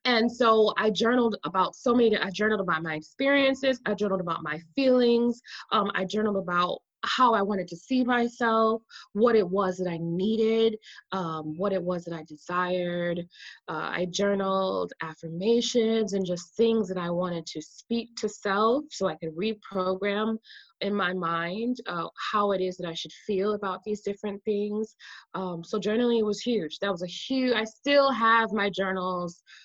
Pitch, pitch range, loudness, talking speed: 205 Hz, 180-225 Hz, -27 LUFS, 175 wpm